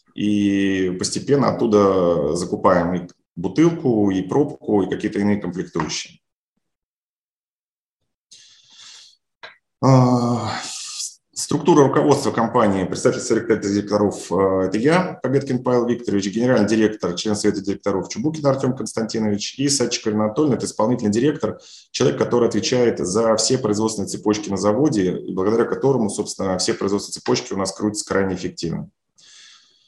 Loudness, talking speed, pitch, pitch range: -20 LUFS, 120 wpm, 105 Hz, 100-120 Hz